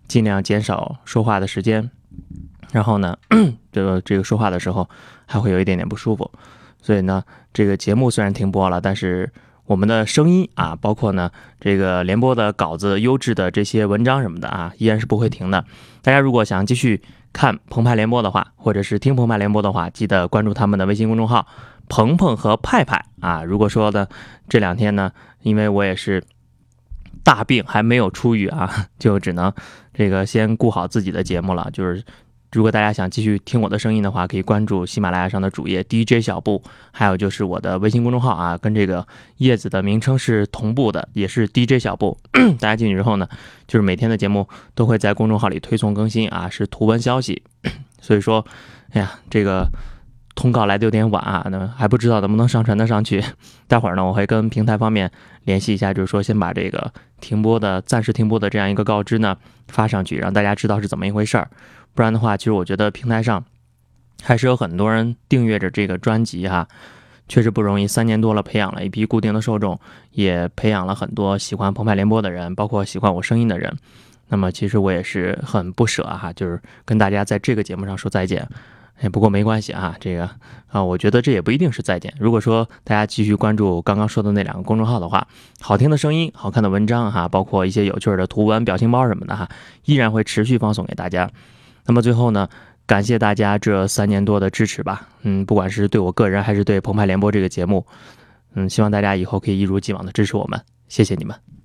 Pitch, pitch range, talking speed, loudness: 105 Hz, 95-115 Hz, 330 characters per minute, -19 LUFS